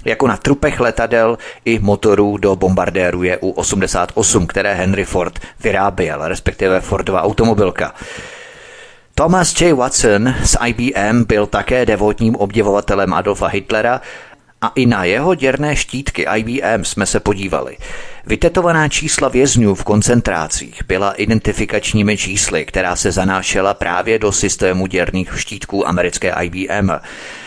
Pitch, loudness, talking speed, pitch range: 105 Hz, -15 LUFS, 120 wpm, 95-125 Hz